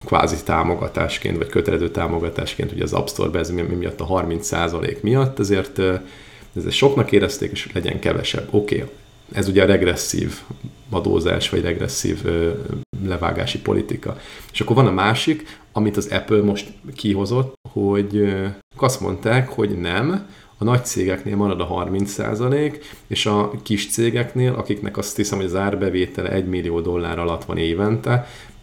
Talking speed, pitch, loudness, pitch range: 155 wpm, 100 Hz, -21 LUFS, 95-115 Hz